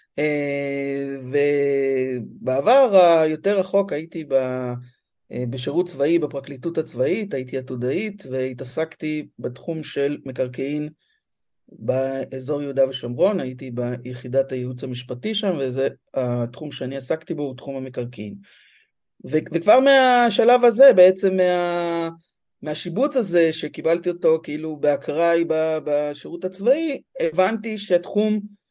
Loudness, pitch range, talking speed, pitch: -21 LUFS, 130-175 Hz, 95 wpm, 150 Hz